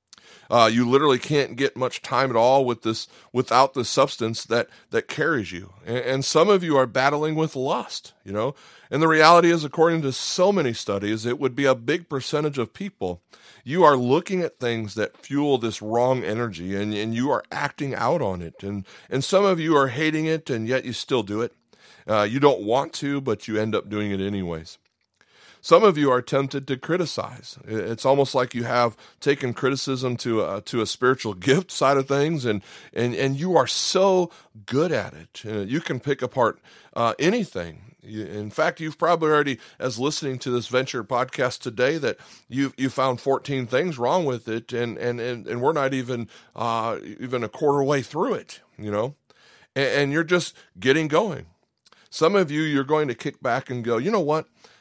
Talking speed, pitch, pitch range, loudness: 205 wpm, 130 Hz, 115-145 Hz, -23 LUFS